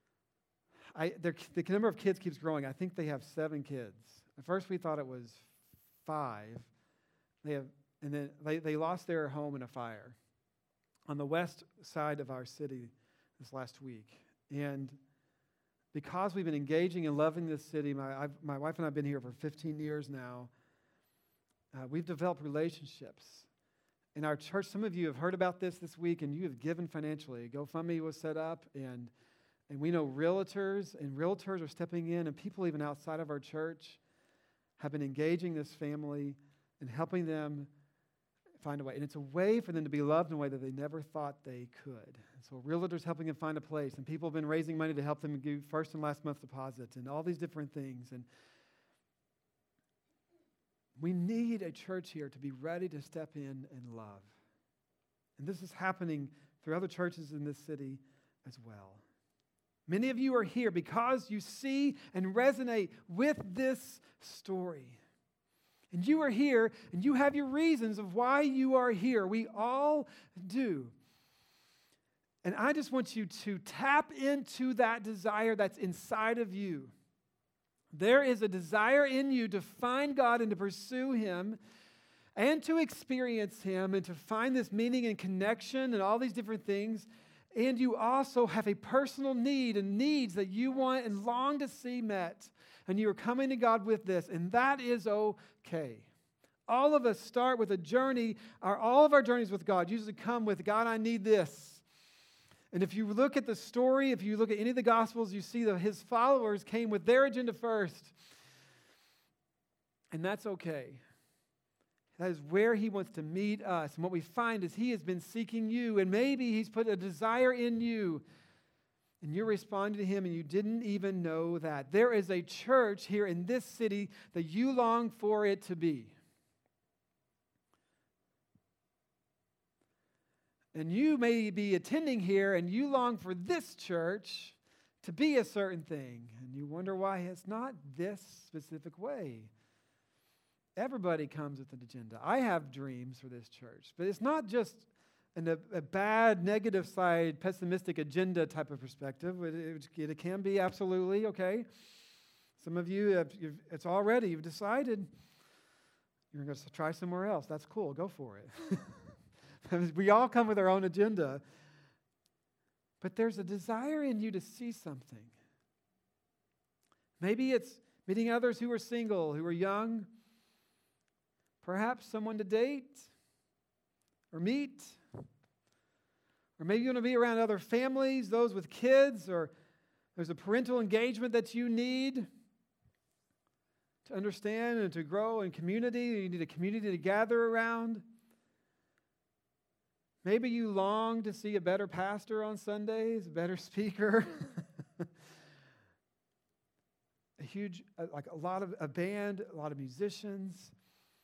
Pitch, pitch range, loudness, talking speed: 185 Hz, 155-225 Hz, -35 LUFS, 170 wpm